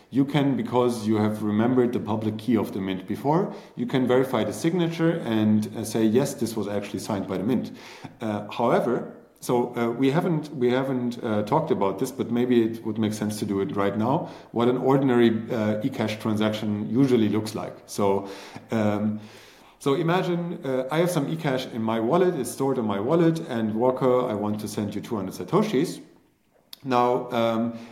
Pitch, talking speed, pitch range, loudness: 120 Hz, 190 wpm, 105-130 Hz, -25 LUFS